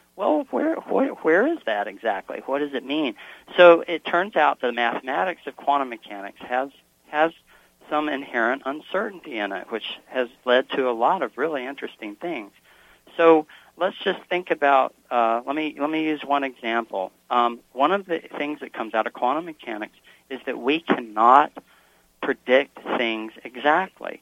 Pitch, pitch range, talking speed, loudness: 140 Hz, 120-165 Hz, 170 wpm, -23 LUFS